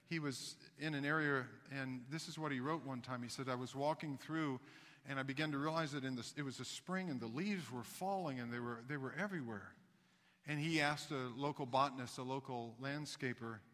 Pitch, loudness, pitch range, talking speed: 140 Hz, -43 LUFS, 130-155 Hz, 225 wpm